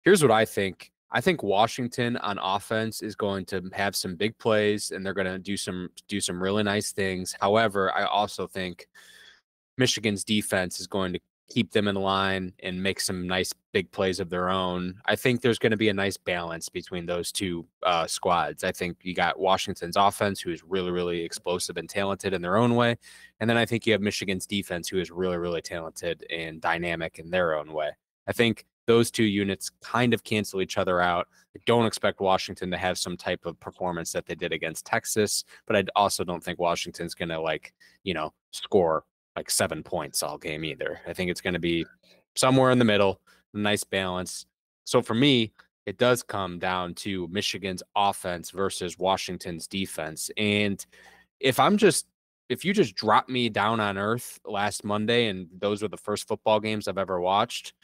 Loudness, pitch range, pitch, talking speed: -27 LUFS, 90-105 Hz, 100 Hz, 195 wpm